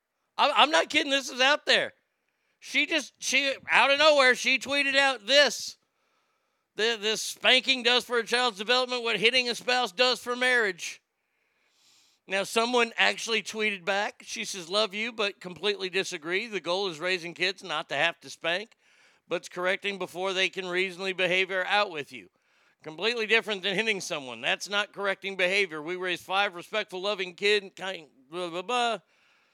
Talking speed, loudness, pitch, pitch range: 175 wpm, -26 LUFS, 205 Hz, 185-245 Hz